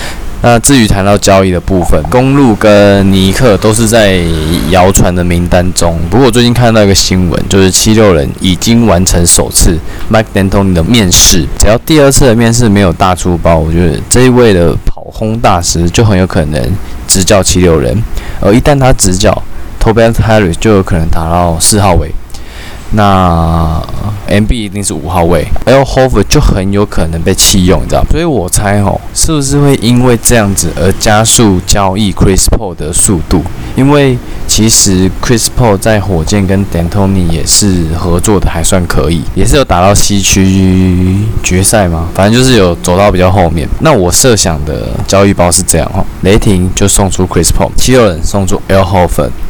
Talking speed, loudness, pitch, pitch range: 315 characters per minute, -7 LUFS, 95 Hz, 85-110 Hz